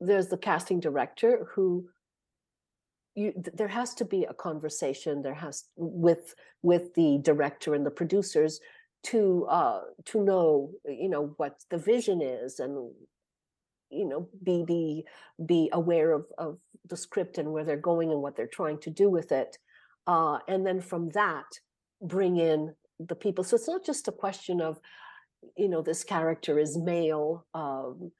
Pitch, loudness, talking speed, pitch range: 170 Hz, -29 LUFS, 165 wpm, 155-195 Hz